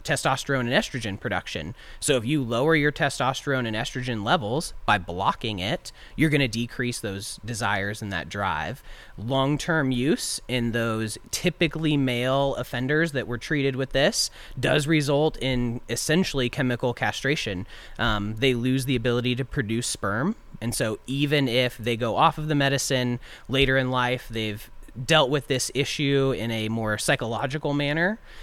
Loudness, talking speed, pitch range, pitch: -25 LUFS, 160 wpm, 115-145 Hz, 130 Hz